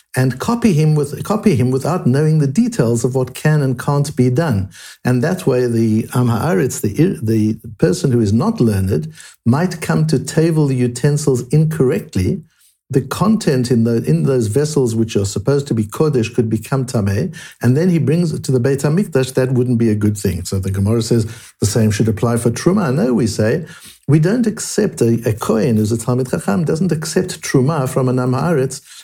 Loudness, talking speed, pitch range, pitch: -16 LUFS, 195 wpm, 115-155 Hz, 130 Hz